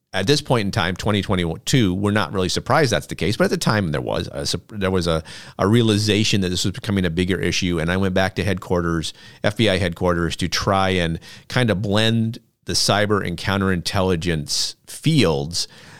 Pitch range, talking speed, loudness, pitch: 90-105 Hz, 190 wpm, -20 LUFS, 95 Hz